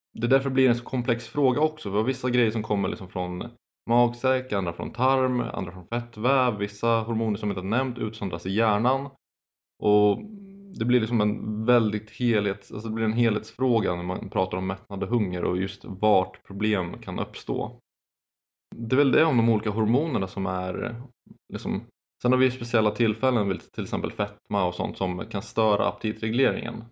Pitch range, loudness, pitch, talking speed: 100-125 Hz, -26 LUFS, 110 Hz, 190 wpm